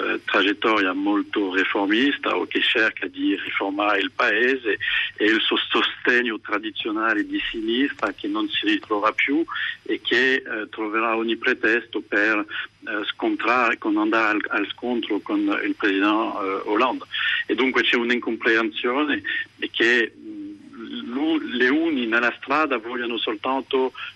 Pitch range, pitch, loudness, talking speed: 295-365 Hz, 315 Hz, -22 LUFS, 130 wpm